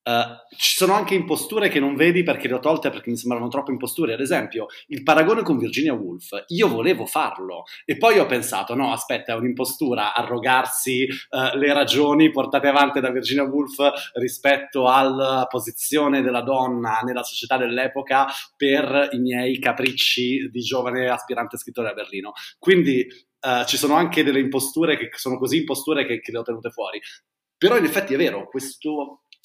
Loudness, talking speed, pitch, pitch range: -21 LUFS, 170 wpm, 135 Hz, 125-145 Hz